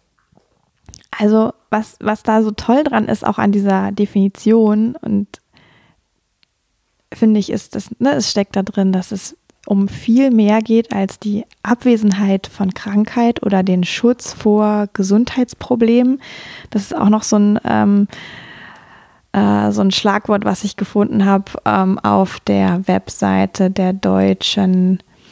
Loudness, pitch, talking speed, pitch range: -15 LUFS, 205 Hz, 140 wpm, 190-225 Hz